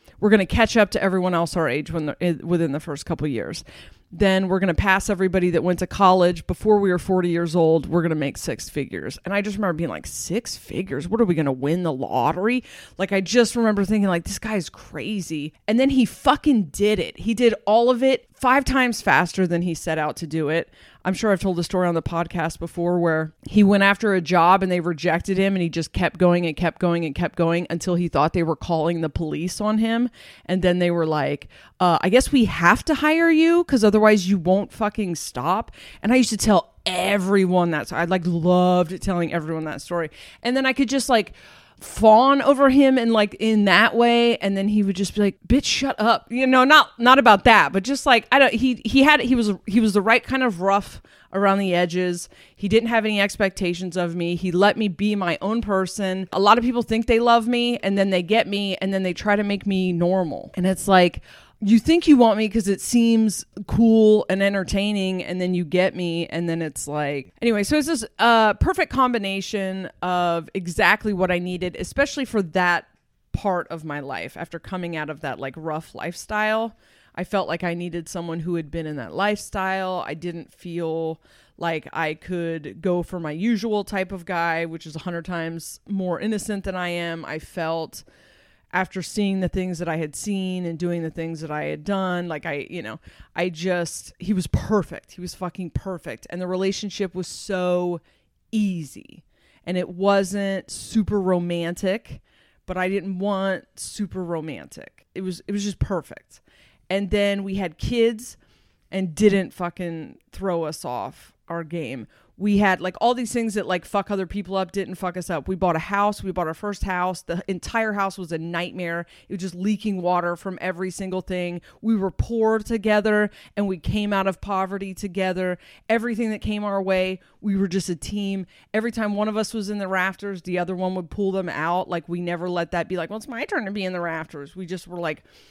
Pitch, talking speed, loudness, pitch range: 185 Hz, 220 wpm, -22 LUFS, 170-210 Hz